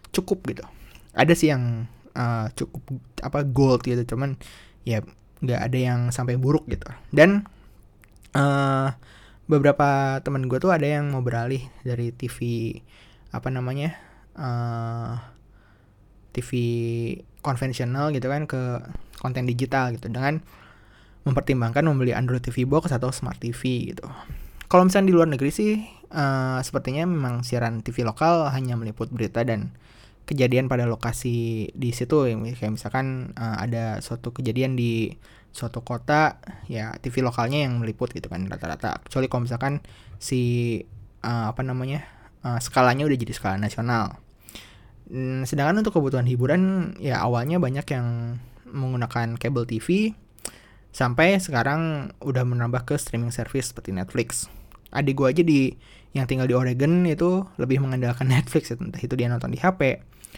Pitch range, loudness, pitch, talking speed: 115-140 Hz, -24 LUFS, 125 Hz, 135 wpm